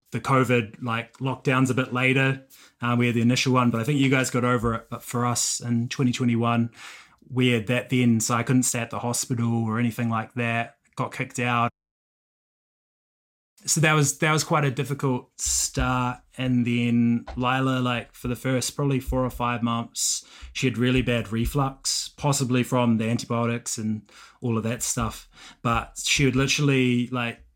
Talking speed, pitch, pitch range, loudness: 180 wpm, 125 Hz, 120-130 Hz, -24 LUFS